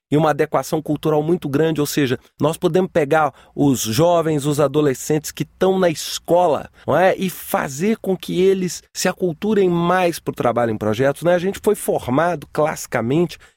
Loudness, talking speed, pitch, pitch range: -19 LUFS, 175 wpm, 160 Hz, 145-180 Hz